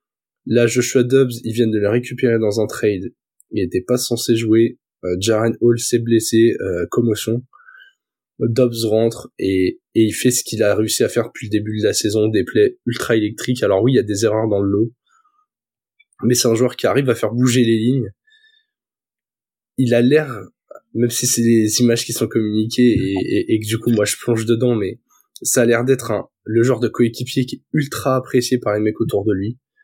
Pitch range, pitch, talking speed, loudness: 110-125 Hz, 120 Hz, 215 wpm, -17 LUFS